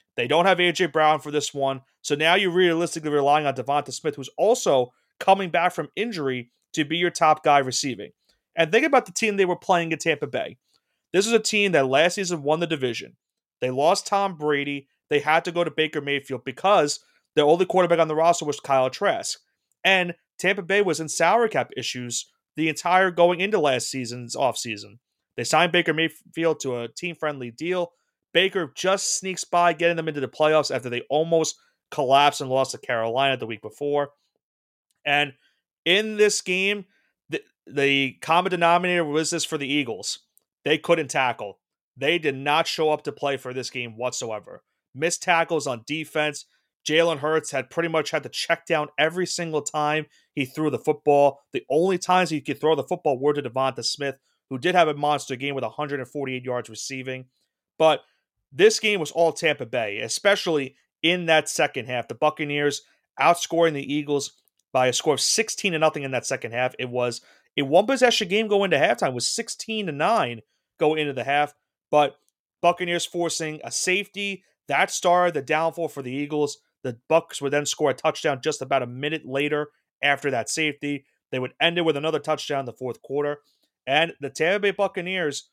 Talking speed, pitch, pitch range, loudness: 190 wpm, 155 Hz, 140-175 Hz, -23 LUFS